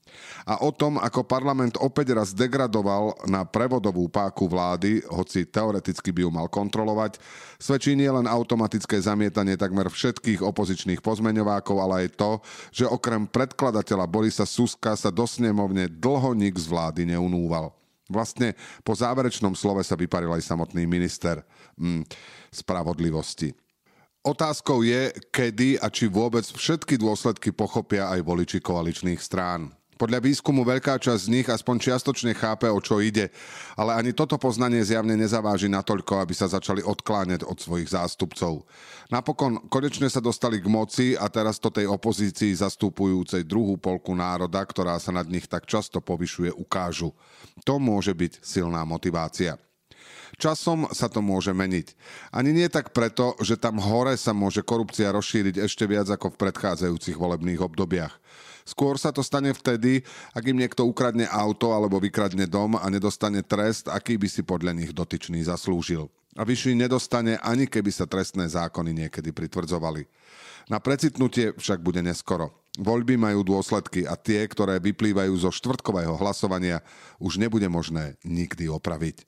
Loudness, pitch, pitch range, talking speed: -25 LUFS, 105 Hz, 90-120 Hz, 150 wpm